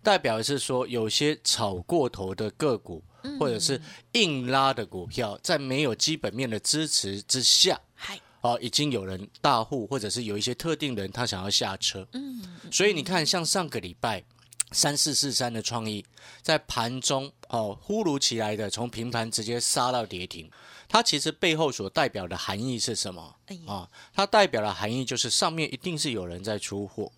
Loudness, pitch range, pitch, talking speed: -26 LUFS, 110-150 Hz, 125 Hz, 265 characters per minute